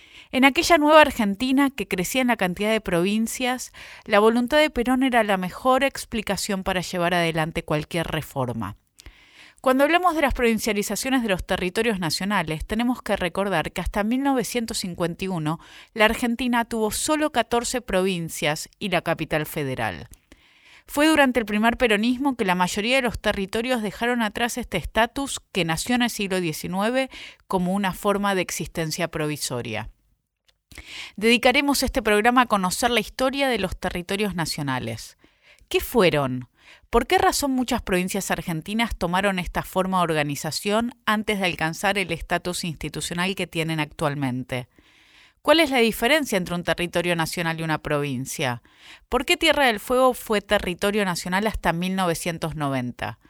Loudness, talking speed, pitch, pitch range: -23 LUFS, 145 wpm, 200 Hz, 170-240 Hz